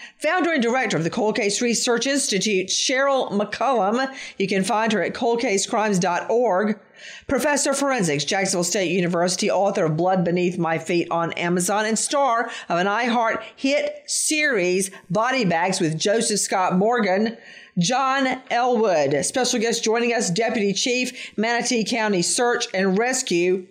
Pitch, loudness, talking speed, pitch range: 215 Hz, -21 LUFS, 145 wpm, 185-245 Hz